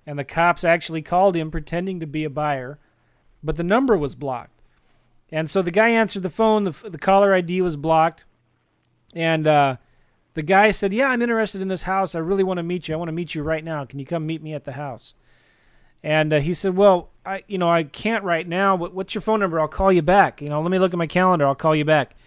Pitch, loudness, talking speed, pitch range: 170 Hz, -20 LUFS, 255 wpm, 155-190 Hz